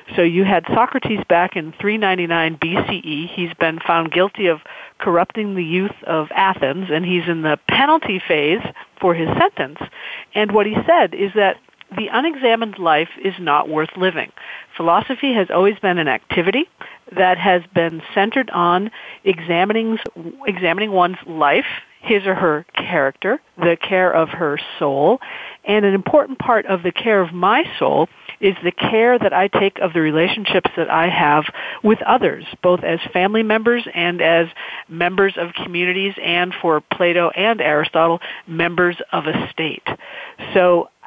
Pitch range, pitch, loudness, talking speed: 170-205 Hz, 180 Hz, -17 LUFS, 155 wpm